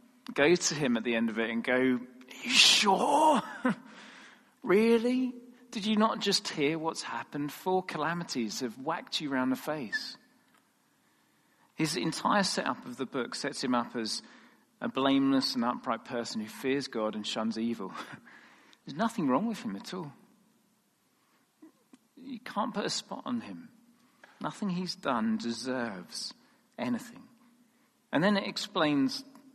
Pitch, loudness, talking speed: 215 Hz, -30 LUFS, 150 wpm